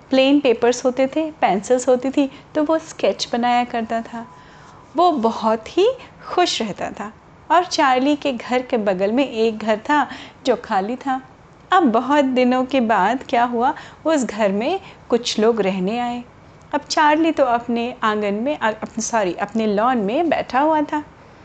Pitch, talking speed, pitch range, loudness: 250 Hz, 170 wpm, 230-295 Hz, -19 LUFS